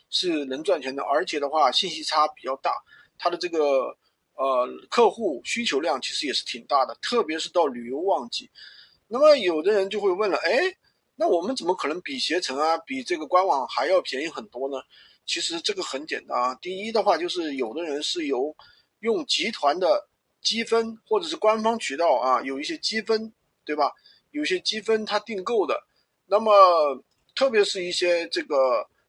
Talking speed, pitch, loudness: 270 characters per minute, 220 Hz, -24 LUFS